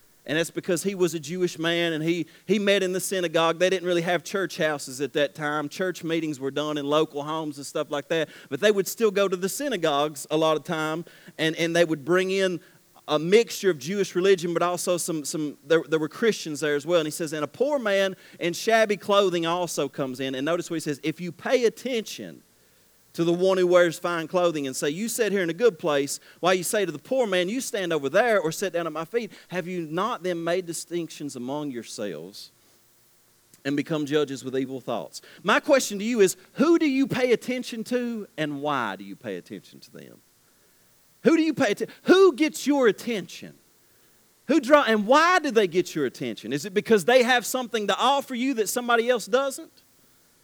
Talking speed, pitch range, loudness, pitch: 225 wpm, 155-210 Hz, -24 LUFS, 175 Hz